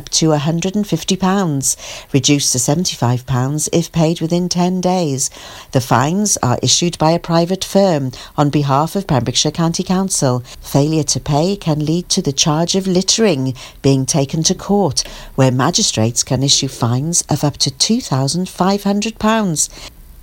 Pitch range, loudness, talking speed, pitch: 135-180 Hz, -15 LUFS, 140 wpm, 155 Hz